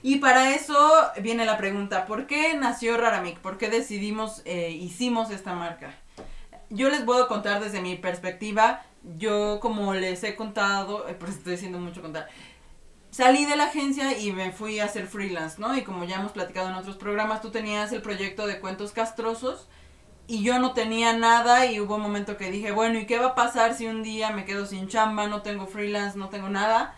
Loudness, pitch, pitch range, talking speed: -25 LUFS, 210 Hz, 195-230 Hz, 205 wpm